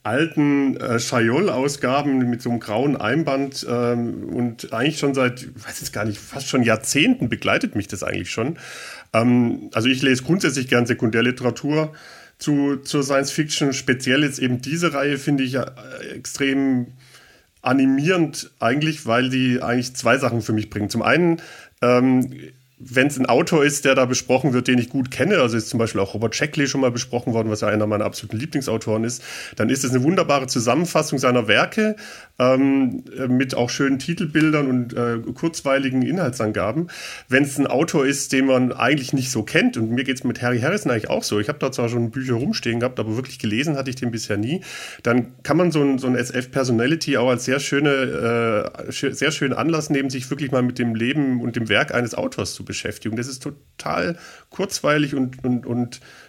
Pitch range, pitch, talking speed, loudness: 120-140 Hz, 130 Hz, 190 wpm, -21 LUFS